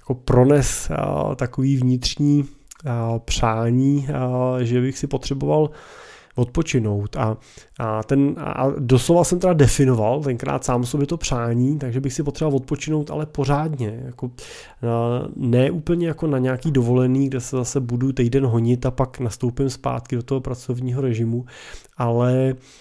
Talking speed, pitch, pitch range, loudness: 145 wpm, 130 Hz, 125-140 Hz, -21 LUFS